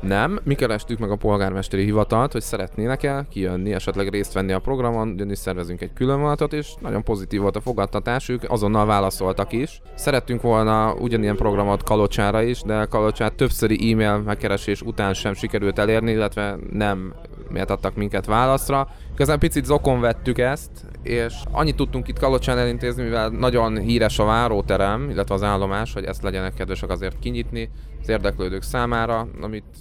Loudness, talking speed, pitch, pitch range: -22 LUFS, 160 wpm, 110 Hz, 100-120 Hz